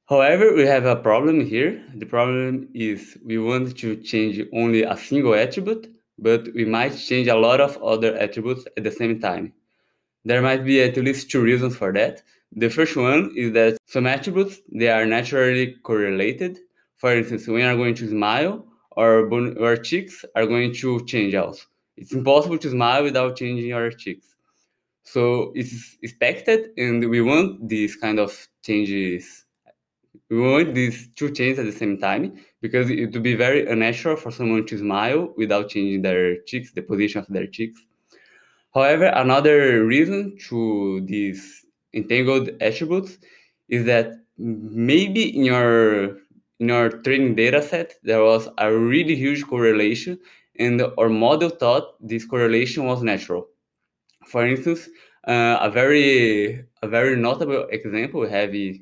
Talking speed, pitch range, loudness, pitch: 155 wpm, 110-130 Hz, -20 LUFS, 120 Hz